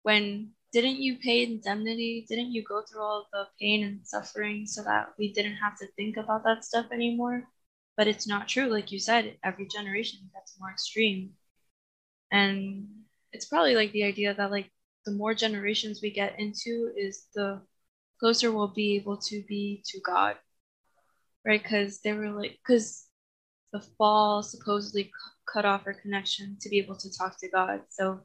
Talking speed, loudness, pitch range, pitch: 175 wpm, -29 LUFS, 200-220 Hz, 210 Hz